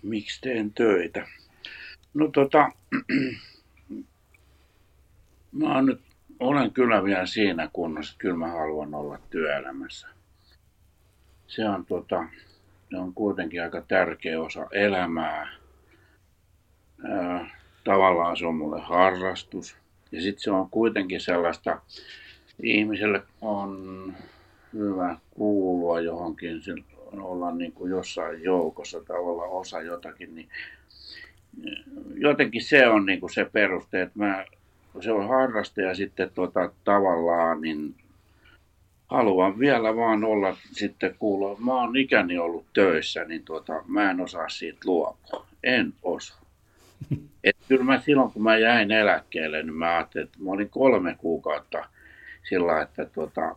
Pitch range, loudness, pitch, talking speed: 85-105 Hz, -25 LUFS, 95 Hz, 125 wpm